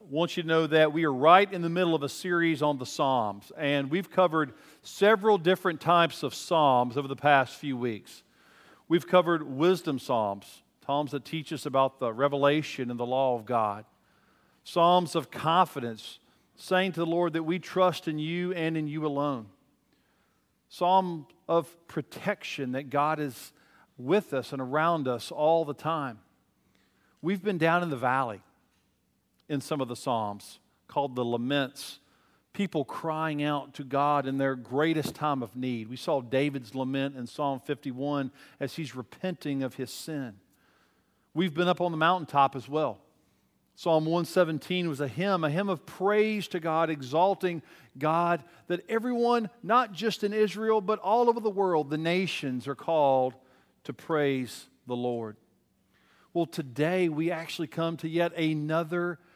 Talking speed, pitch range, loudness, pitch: 165 wpm, 135-175 Hz, -28 LUFS, 155 Hz